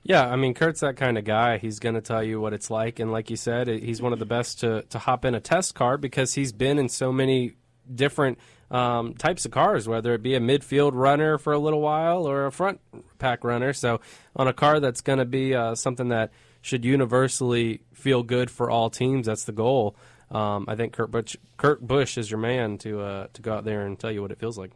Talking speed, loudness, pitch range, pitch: 245 wpm, -25 LUFS, 115-135 Hz, 125 Hz